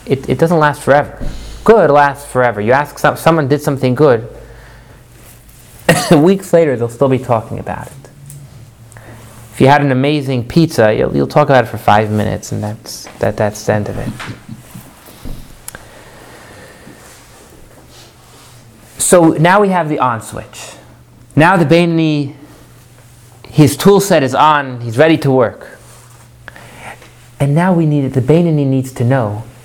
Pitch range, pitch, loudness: 120-150 Hz, 130 Hz, -12 LUFS